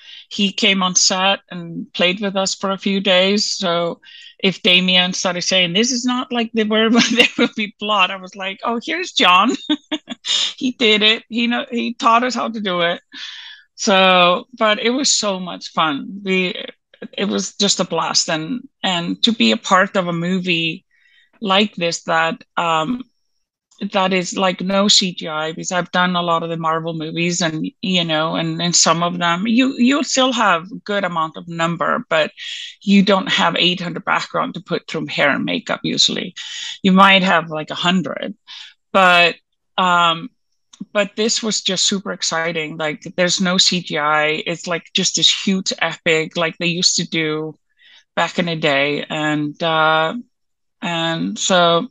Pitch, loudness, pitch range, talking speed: 190 Hz, -17 LUFS, 170-230 Hz, 175 wpm